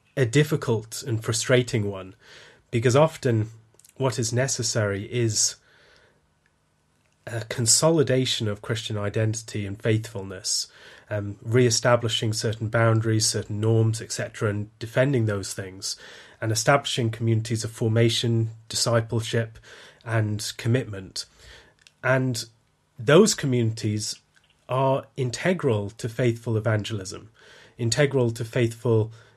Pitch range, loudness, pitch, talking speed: 110-125 Hz, -24 LUFS, 115 Hz, 100 wpm